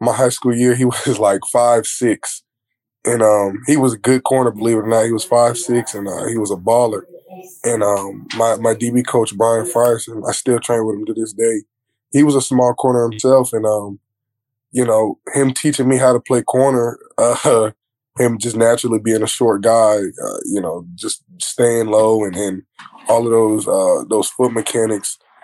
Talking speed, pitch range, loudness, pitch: 205 wpm, 110-125 Hz, -16 LUFS, 120 Hz